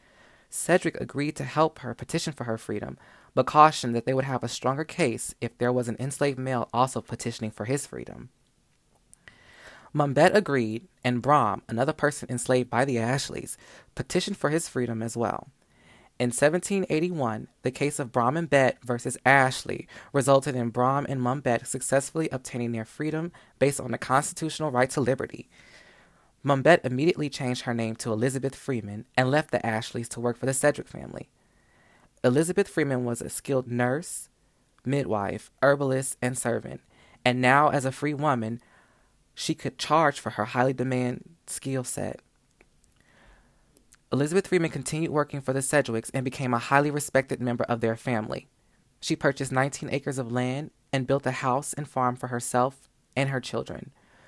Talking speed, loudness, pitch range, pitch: 165 wpm, -26 LUFS, 120-145 Hz, 130 Hz